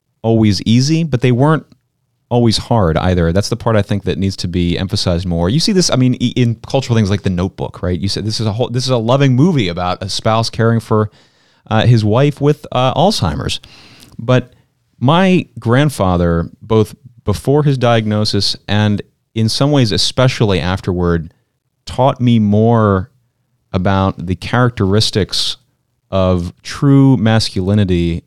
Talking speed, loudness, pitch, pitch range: 160 wpm, -14 LUFS, 115 Hz, 95-125 Hz